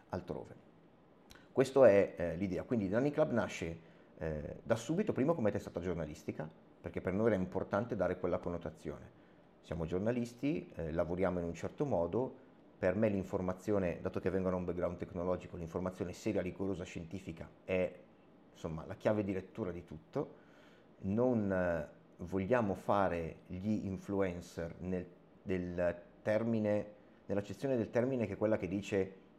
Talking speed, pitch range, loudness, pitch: 145 wpm, 85-105 Hz, -37 LUFS, 95 Hz